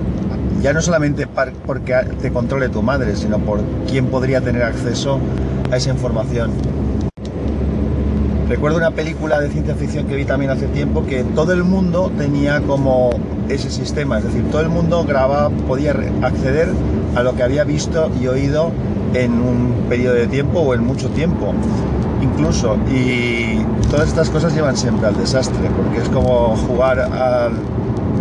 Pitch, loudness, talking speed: 115 Hz, -17 LUFS, 155 wpm